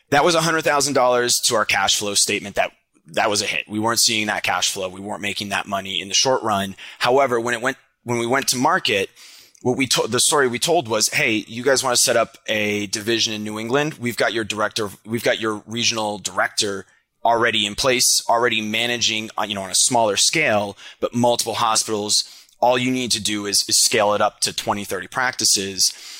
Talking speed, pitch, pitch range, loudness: 220 wpm, 115 Hz, 105-125 Hz, -19 LUFS